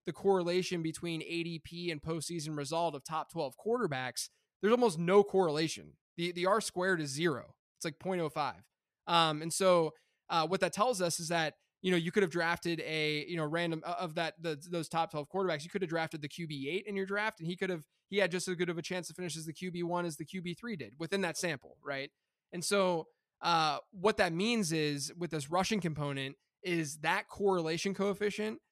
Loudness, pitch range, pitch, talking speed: -34 LUFS, 160-190 Hz, 170 Hz, 215 wpm